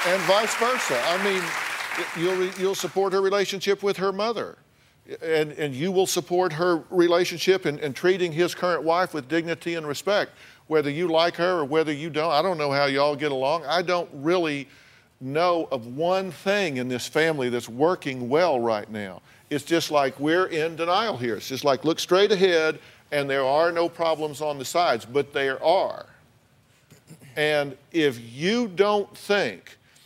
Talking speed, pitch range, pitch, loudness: 180 wpm, 140-180 Hz, 160 Hz, -24 LUFS